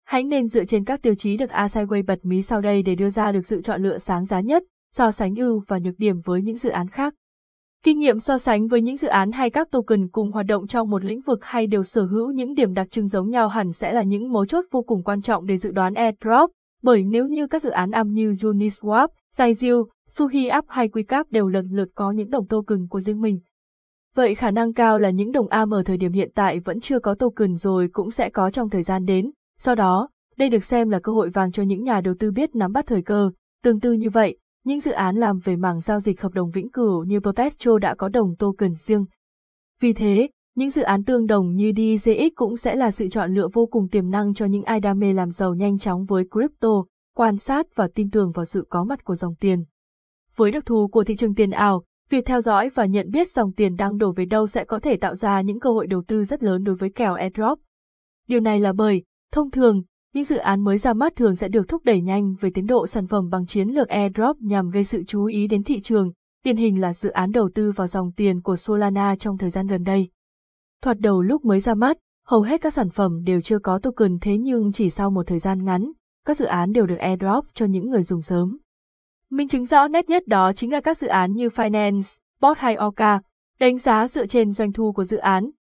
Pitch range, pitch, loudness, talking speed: 195-240 Hz, 215 Hz, -21 LUFS, 250 wpm